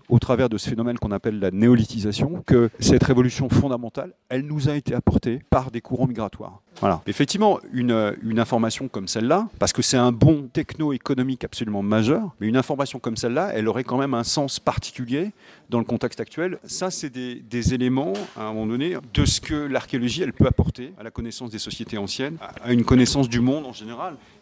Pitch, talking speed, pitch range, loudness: 125 Hz, 205 wpm, 115-135 Hz, -23 LUFS